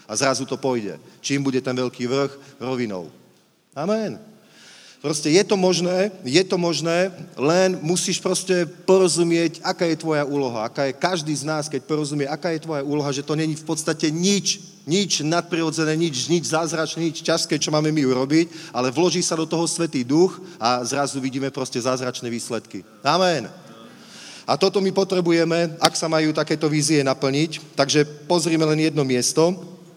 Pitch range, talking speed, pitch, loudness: 140-175 Hz, 165 wpm, 160 Hz, -21 LUFS